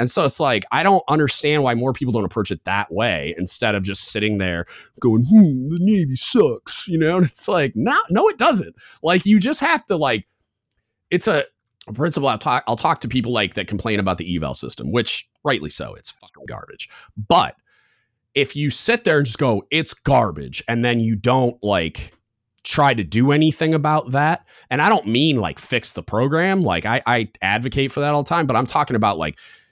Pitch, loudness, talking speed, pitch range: 130 Hz, -18 LUFS, 215 wpm, 110-160 Hz